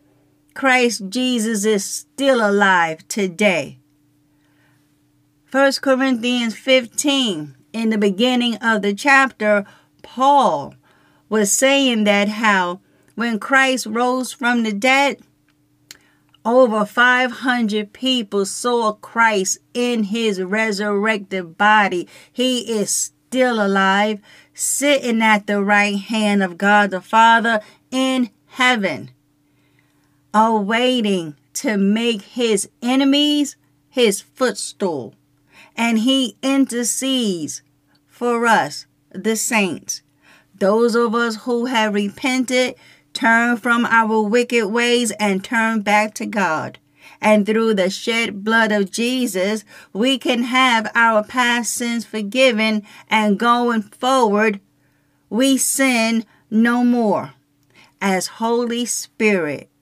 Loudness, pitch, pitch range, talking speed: -17 LUFS, 220 Hz, 200-245 Hz, 105 wpm